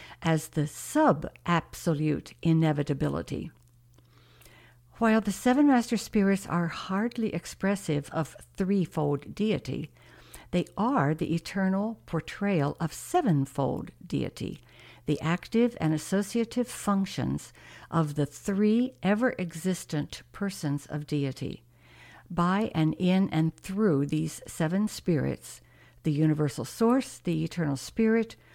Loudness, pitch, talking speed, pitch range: -28 LUFS, 165 Hz, 105 wpm, 145-200 Hz